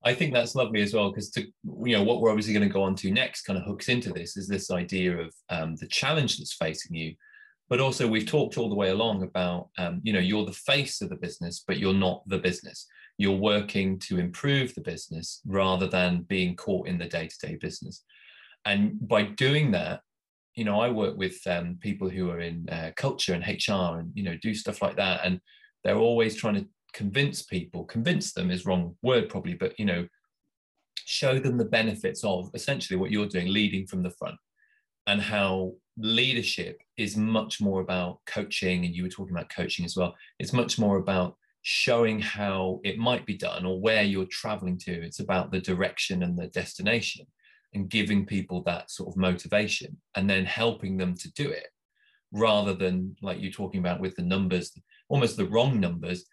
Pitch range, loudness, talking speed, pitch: 90-110 Hz, -28 LUFS, 205 wpm, 95 Hz